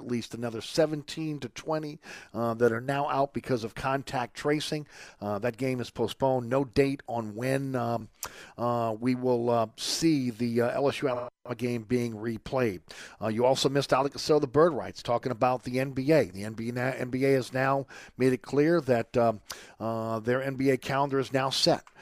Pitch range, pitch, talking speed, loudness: 120-135 Hz, 125 Hz, 175 wpm, -29 LUFS